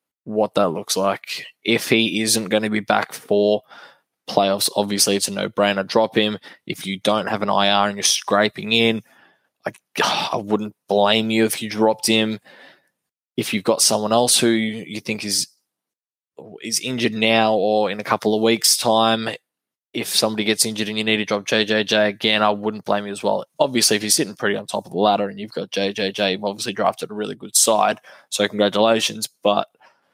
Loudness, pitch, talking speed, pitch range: -19 LUFS, 110 Hz, 195 wpm, 105-110 Hz